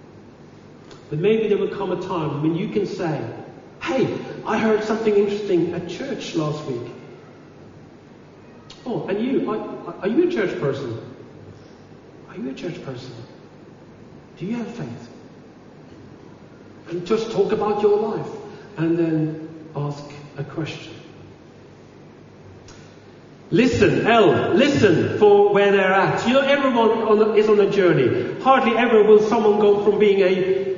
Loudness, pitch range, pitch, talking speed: -19 LUFS, 170-215 Hz, 205 Hz, 140 wpm